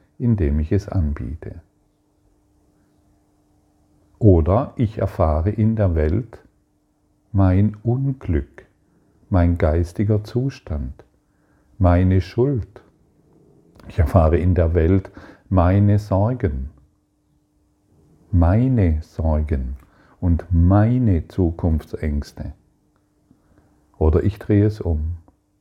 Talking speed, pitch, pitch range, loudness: 80 wpm, 95 Hz, 80-105 Hz, -20 LUFS